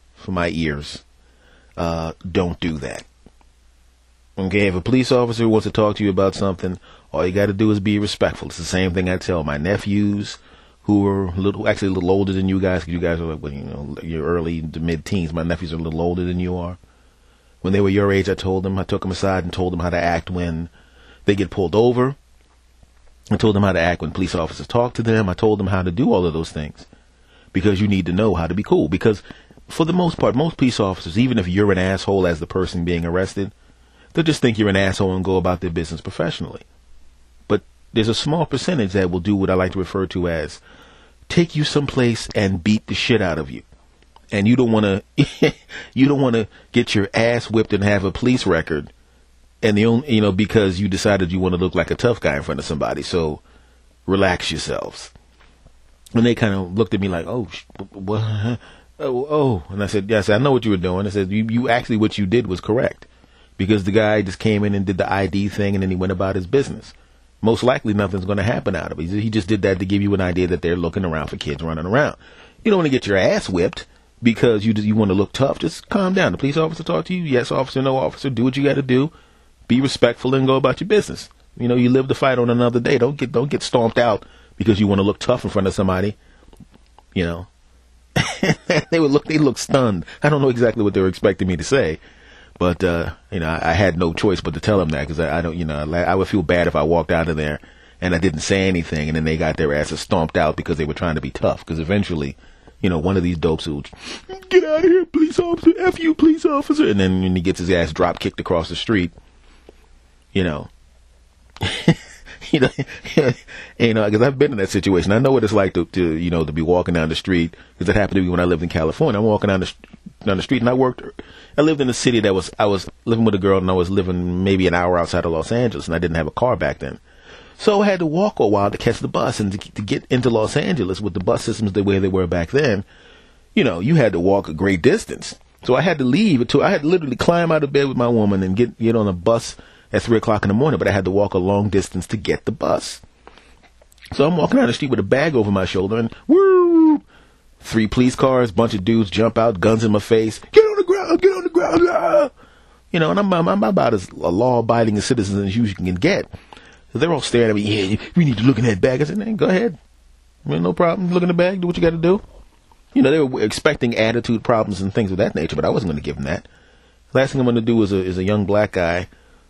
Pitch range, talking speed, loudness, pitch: 85-120 Hz, 260 wpm, -19 LUFS, 100 Hz